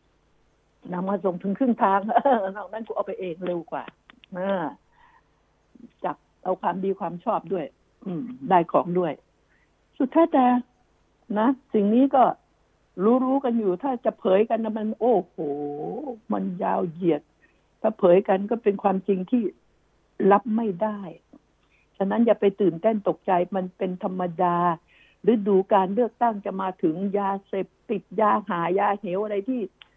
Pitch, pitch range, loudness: 200 Hz, 185-225 Hz, -24 LUFS